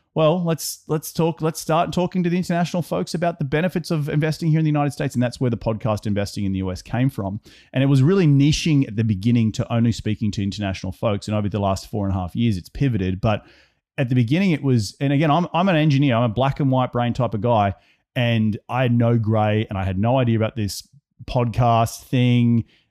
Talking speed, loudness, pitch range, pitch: 240 wpm, -21 LUFS, 110-150 Hz, 120 Hz